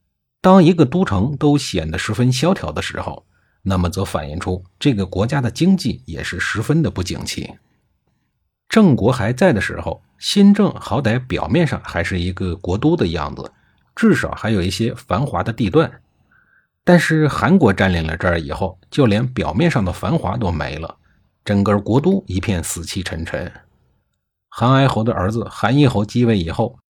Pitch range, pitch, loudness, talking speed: 90-140 Hz, 110 Hz, -18 LUFS, 255 characters per minute